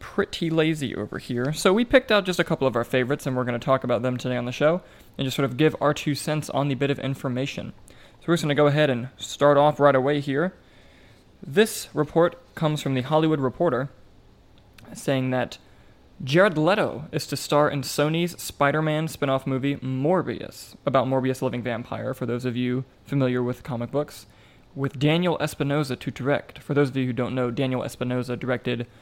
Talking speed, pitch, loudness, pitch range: 205 wpm, 135 Hz, -24 LUFS, 125-150 Hz